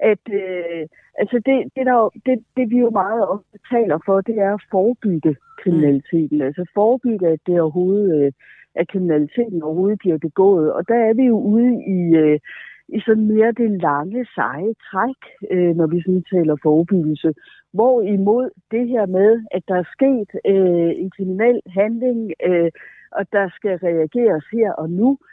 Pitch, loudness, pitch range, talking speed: 195 Hz, -18 LUFS, 170-225 Hz, 165 wpm